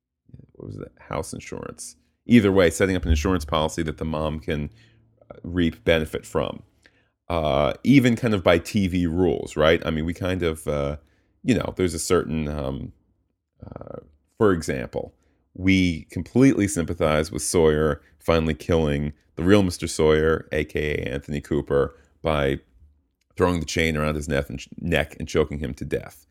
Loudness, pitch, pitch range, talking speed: -23 LUFS, 80 Hz, 75-90 Hz, 155 wpm